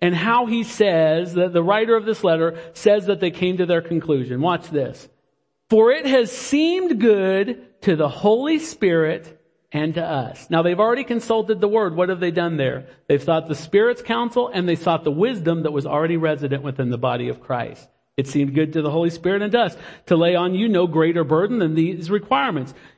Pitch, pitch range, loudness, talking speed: 175 Hz, 160-220 Hz, -20 LUFS, 210 wpm